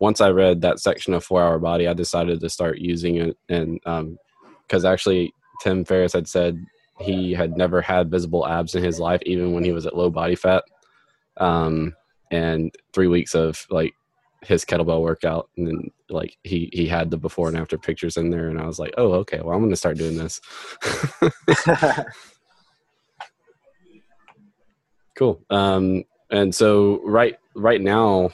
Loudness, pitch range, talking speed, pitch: -21 LUFS, 85-90 Hz, 175 wpm, 85 Hz